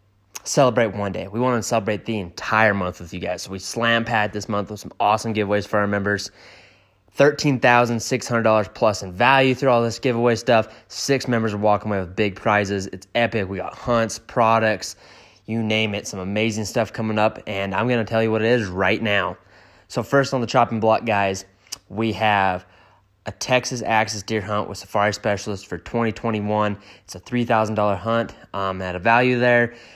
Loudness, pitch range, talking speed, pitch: -21 LUFS, 100-115 Hz, 200 wpm, 110 Hz